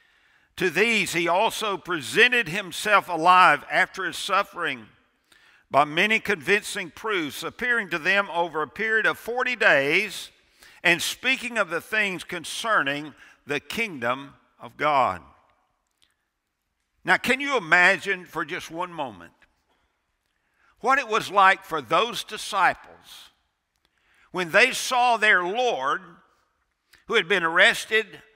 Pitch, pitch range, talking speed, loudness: 195 Hz, 170-220 Hz, 120 wpm, -22 LUFS